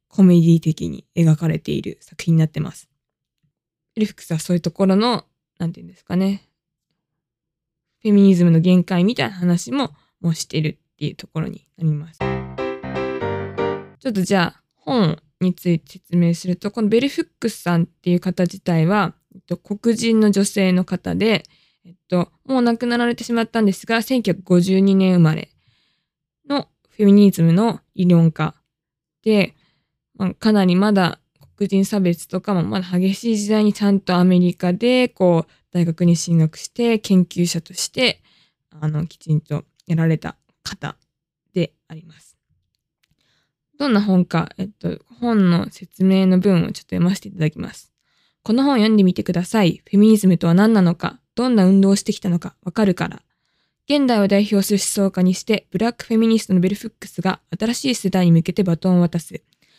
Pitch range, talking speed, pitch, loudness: 165-205 Hz, 335 characters per minute, 185 Hz, -18 LUFS